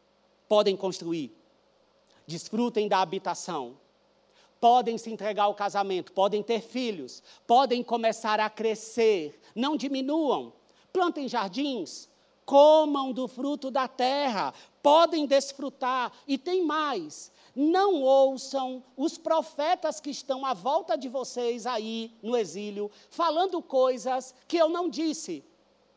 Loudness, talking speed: -27 LUFS, 115 wpm